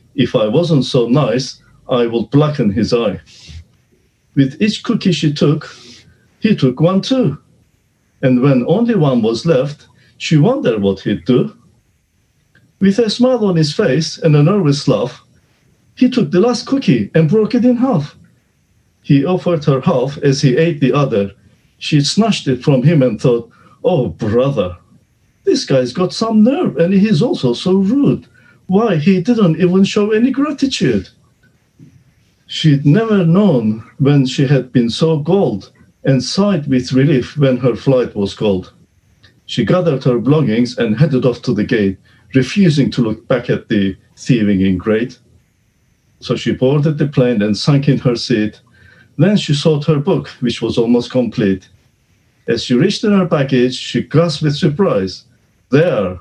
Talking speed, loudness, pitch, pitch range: 160 wpm, -14 LUFS, 140 Hz, 120-175 Hz